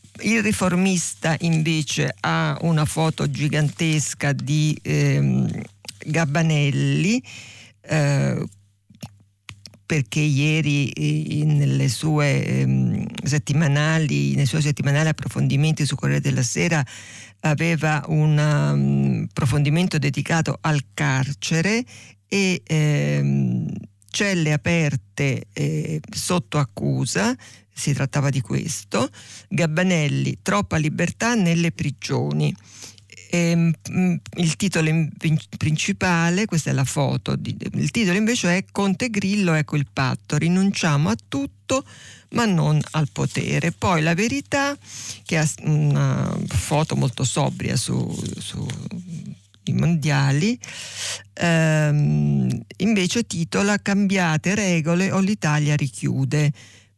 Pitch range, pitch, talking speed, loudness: 130-170 Hz, 150 Hz, 95 wpm, -21 LUFS